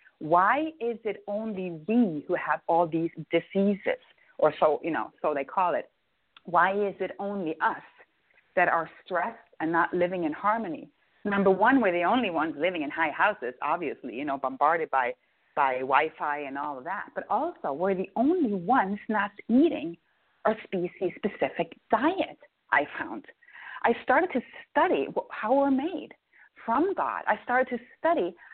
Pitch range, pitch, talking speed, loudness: 175-255 Hz, 205 Hz, 165 wpm, -27 LUFS